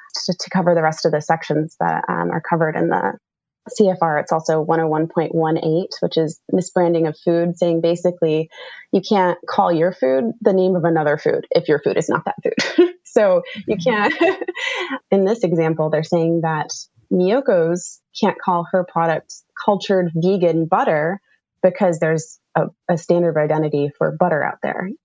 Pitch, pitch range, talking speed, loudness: 170 Hz, 160-190 Hz, 170 wpm, -19 LUFS